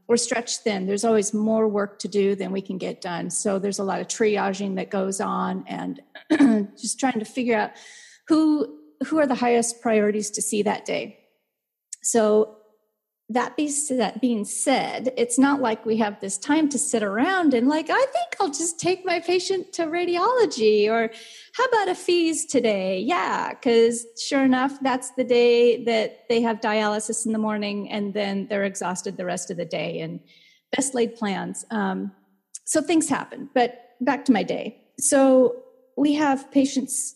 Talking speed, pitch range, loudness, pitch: 180 wpm, 210-275 Hz, -23 LUFS, 235 Hz